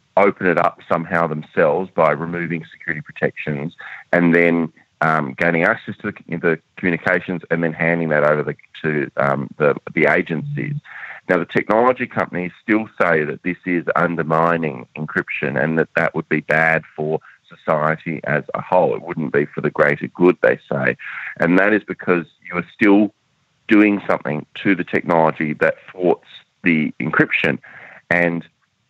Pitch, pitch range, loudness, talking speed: 85 Hz, 80-90 Hz, -19 LUFS, 160 wpm